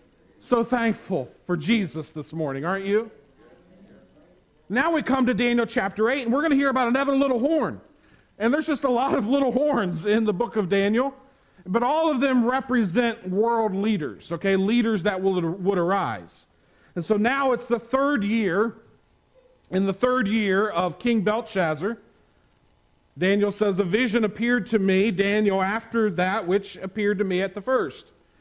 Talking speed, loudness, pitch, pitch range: 170 wpm, -23 LUFS, 215 Hz, 195-250 Hz